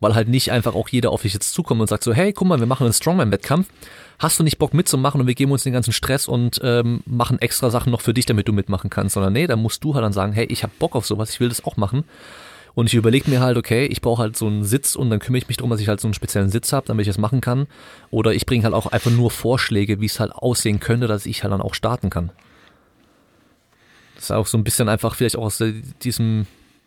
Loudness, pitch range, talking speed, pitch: -19 LUFS, 110-125 Hz, 280 wpm, 115 Hz